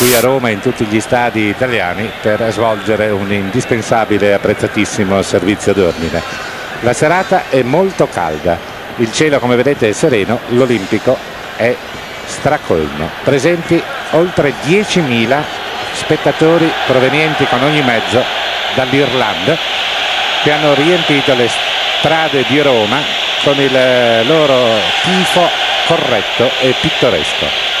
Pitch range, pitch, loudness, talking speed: 110-150 Hz, 130 Hz, -12 LUFS, 115 wpm